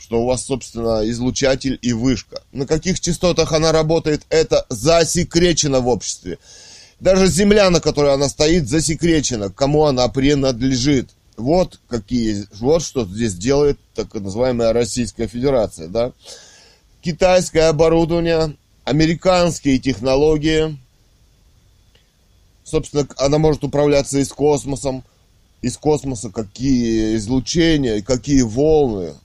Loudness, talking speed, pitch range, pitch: -17 LUFS, 110 wpm, 115-155 Hz, 135 Hz